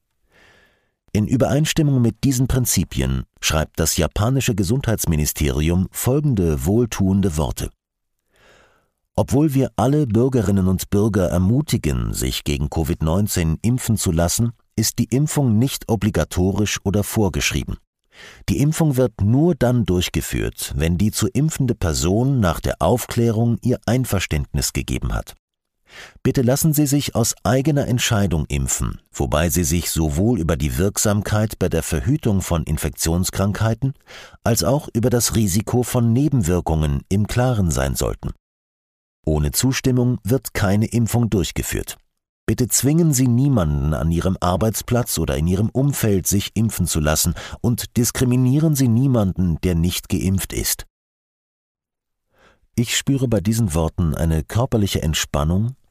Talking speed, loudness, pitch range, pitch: 125 wpm, -19 LUFS, 85-125 Hz, 105 Hz